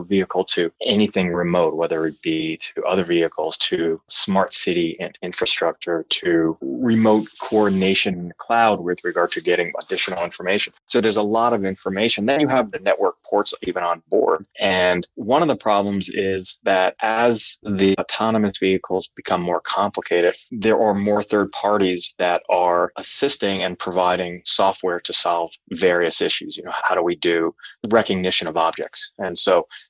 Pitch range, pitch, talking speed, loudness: 85-105 Hz, 95 Hz, 165 wpm, -19 LUFS